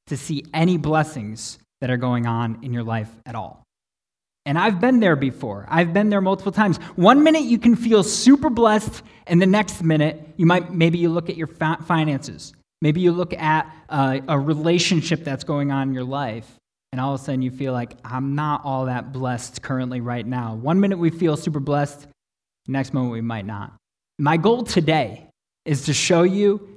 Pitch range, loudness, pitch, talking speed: 130-175 Hz, -20 LUFS, 150 Hz, 200 wpm